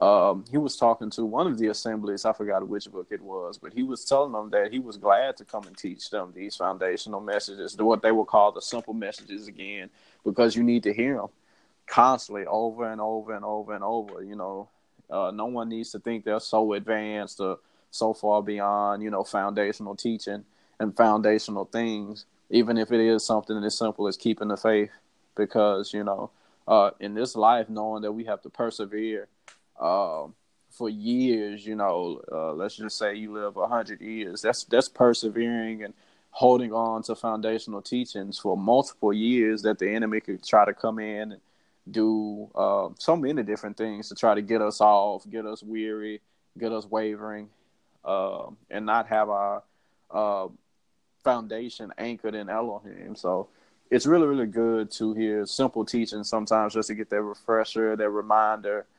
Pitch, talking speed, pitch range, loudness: 110 Hz, 185 wpm, 105-115 Hz, -26 LUFS